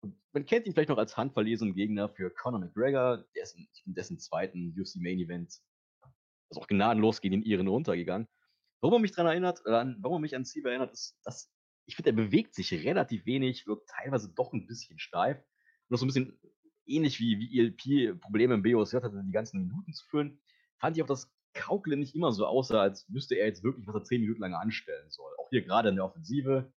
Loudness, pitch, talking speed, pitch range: -31 LUFS, 125 Hz, 225 wpm, 110-155 Hz